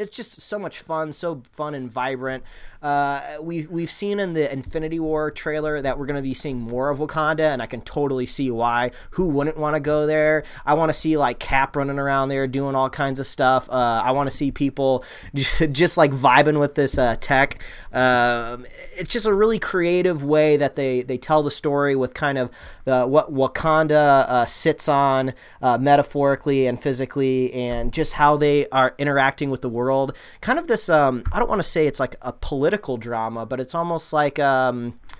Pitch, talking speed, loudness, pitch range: 140 Hz, 205 wpm, -21 LUFS, 130-155 Hz